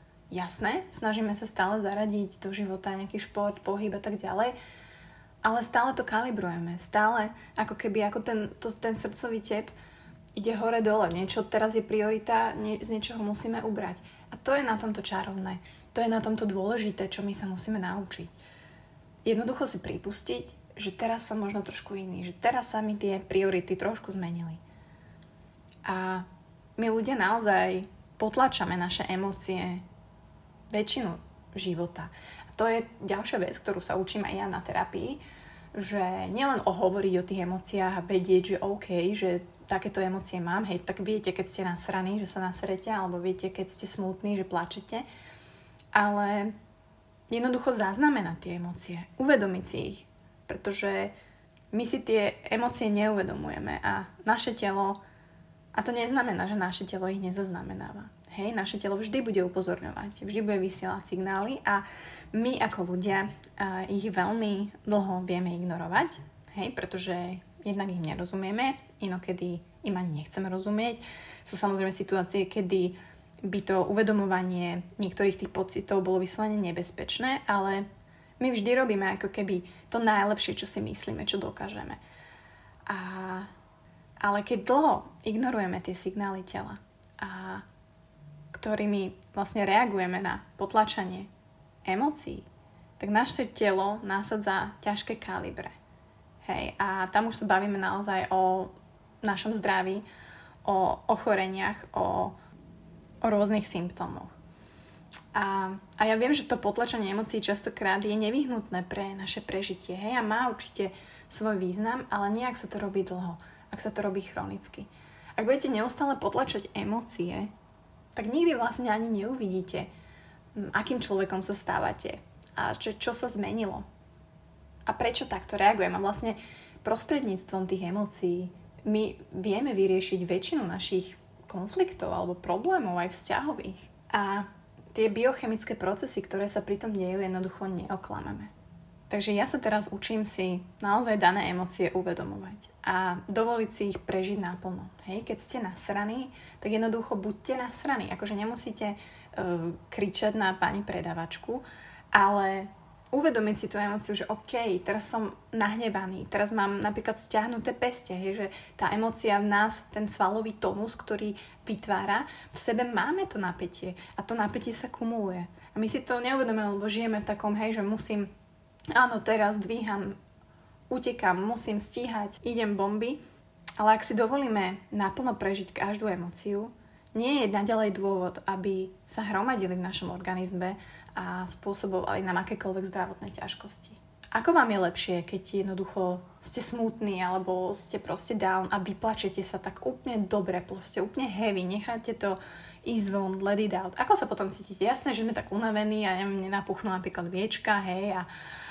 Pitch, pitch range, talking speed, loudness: 200 Hz, 185-220 Hz, 145 wpm, -30 LUFS